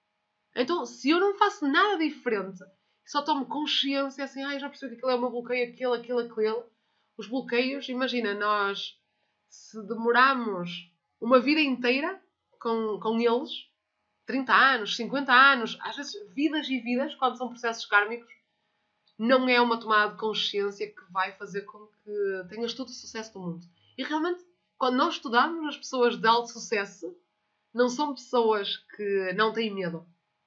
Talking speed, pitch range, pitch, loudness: 160 wpm, 210-275 Hz, 240 Hz, -27 LUFS